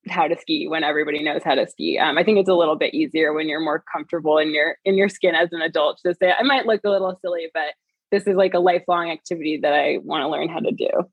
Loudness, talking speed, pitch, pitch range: -20 LUFS, 280 wpm, 175 Hz, 155-195 Hz